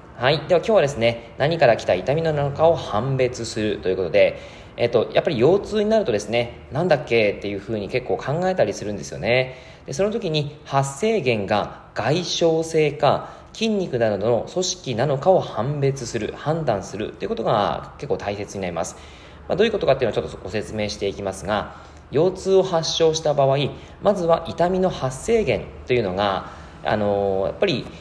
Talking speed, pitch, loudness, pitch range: 380 characters per minute, 135 Hz, -22 LUFS, 110-165 Hz